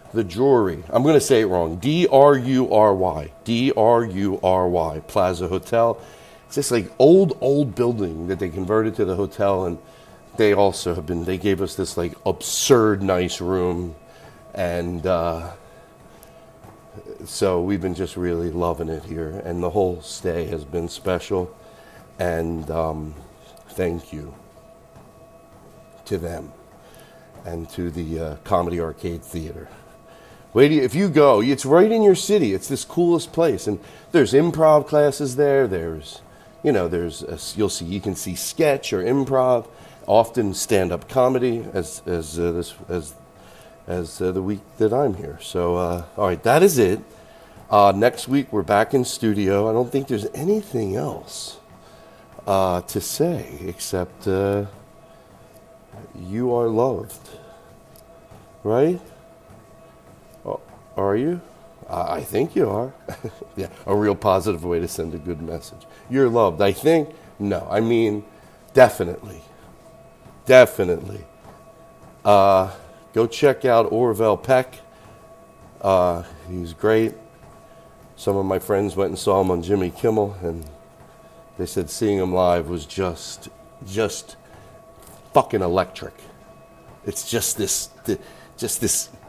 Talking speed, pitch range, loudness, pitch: 145 wpm, 85-125 Hz, -21 LUFS, 100 Hz